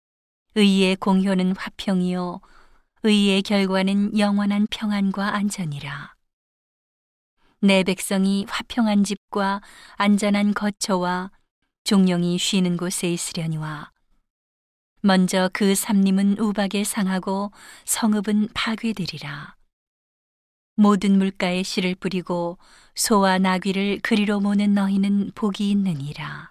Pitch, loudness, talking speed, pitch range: 195 Hz, -21 LUFS, 225 characters per minute, 185-205 Hz